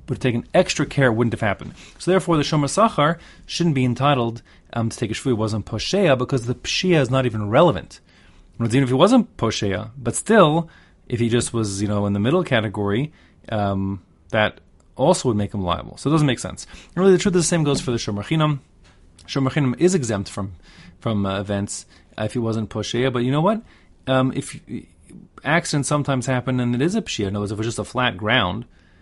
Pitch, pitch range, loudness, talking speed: 120 Hz, 105-145 Hz, -21 LUFS, 225 wpm